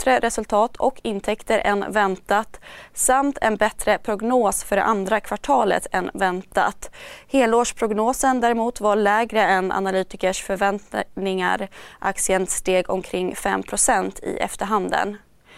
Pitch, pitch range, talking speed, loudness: 210 Hz, 190-230 Hz, 110 wpm, -21 LUFS